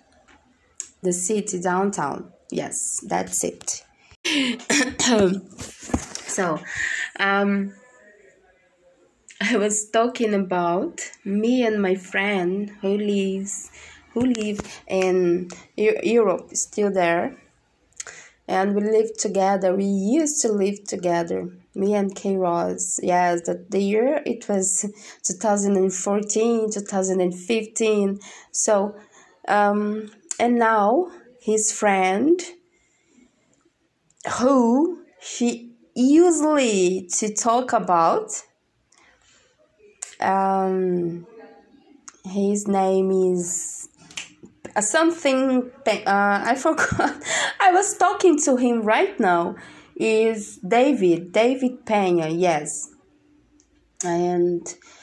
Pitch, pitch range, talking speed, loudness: 205 Hz, 190-245 Hz, 85 wpm, -22 LUFS